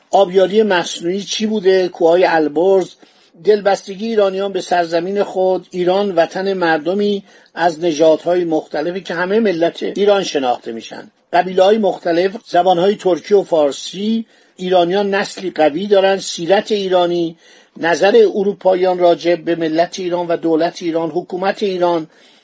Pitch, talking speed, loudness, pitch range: 180 Hz, 130 wpm, -15 LUFS, 170-195 Hz